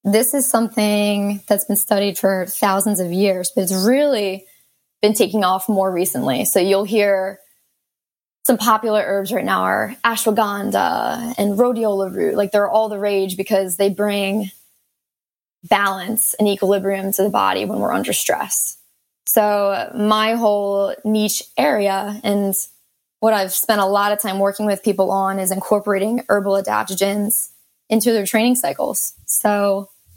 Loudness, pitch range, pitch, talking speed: -18 LUFS, 195-215 Hz, 205 Hz, 150 wpm